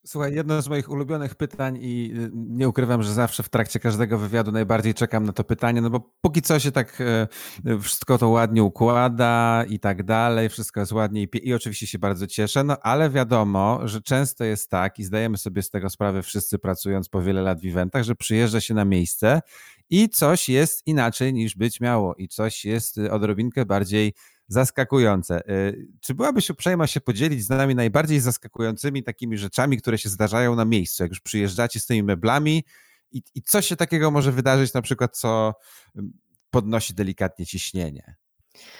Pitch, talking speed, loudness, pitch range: 115 Hz, 175 wpm, -22 LUFS, 105-130 Hz